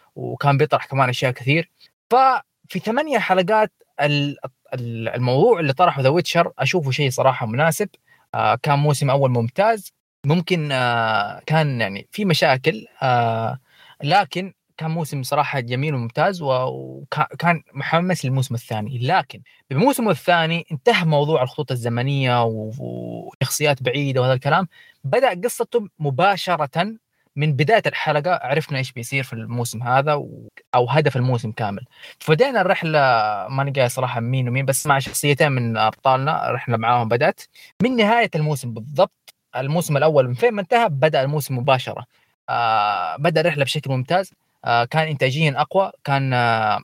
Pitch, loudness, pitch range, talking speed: 145 Hz, -20 LUFS, 125-170 Hz, 135 wpm